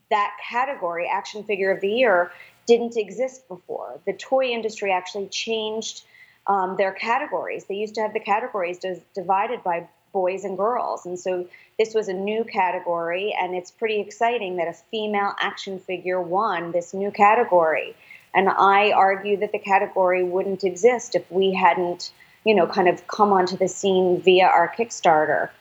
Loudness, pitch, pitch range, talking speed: -22 LUFS, 195 Hz, 180-220 Hz, 165 wpm